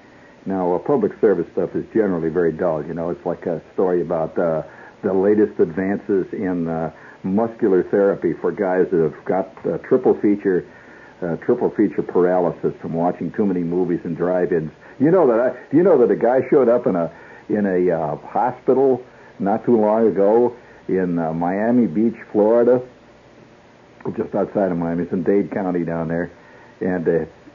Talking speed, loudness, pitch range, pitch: 175 wpm, -19 LUFS, 85-110 Hz, 95 Hz